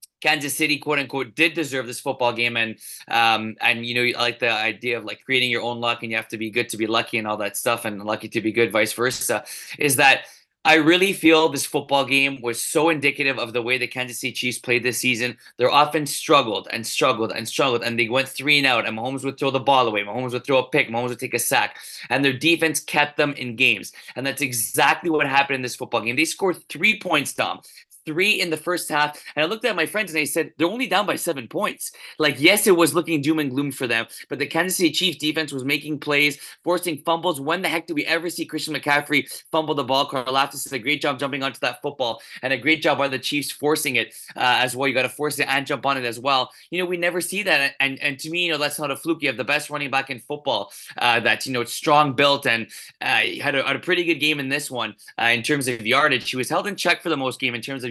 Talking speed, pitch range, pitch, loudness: 275 wpm, 125-155 Hz, 140 Hz, -21 LUFS